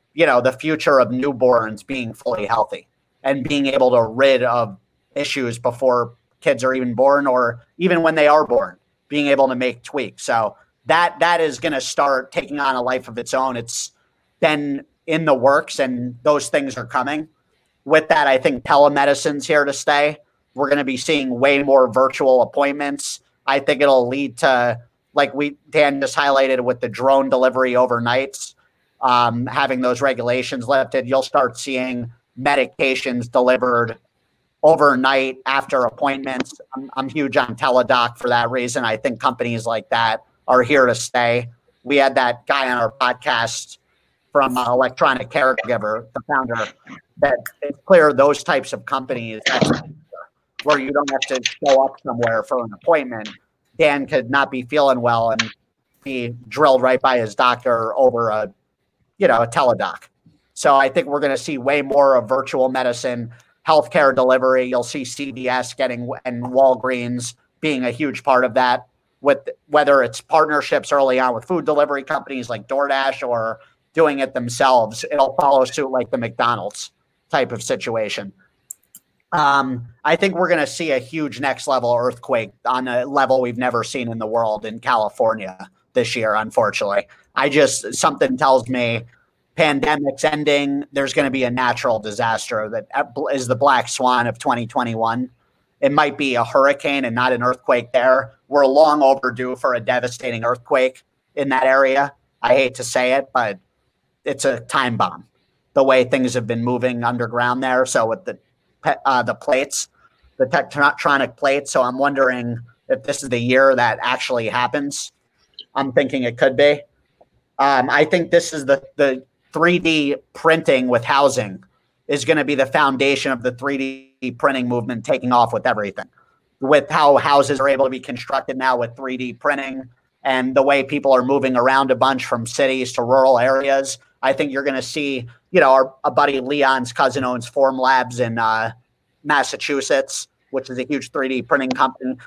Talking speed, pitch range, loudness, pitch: 170 wpm, 125-140 Hz, -18 LUFS, 130 Hz